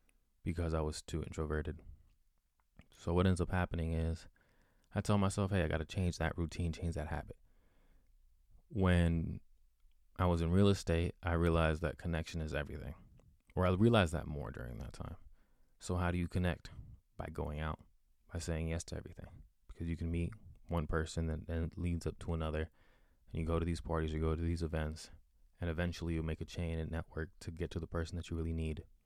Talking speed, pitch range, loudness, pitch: 200 wpm, 80-85 Hz, -38 LUFS, 85 Hz